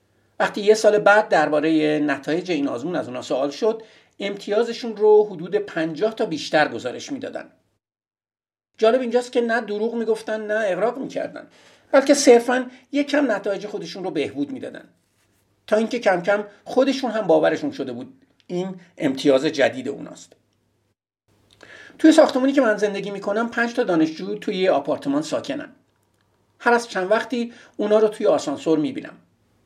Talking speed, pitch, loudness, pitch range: 145 wpm, 215 Hz, -21 LUFS, 175-250 Hz